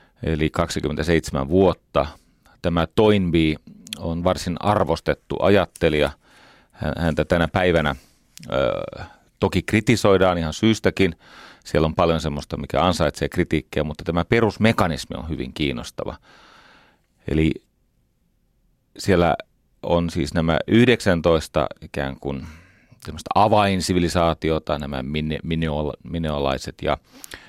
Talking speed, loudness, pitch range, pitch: 100 wpm, -21 LUFS, 75-90 Hz, 85 Hz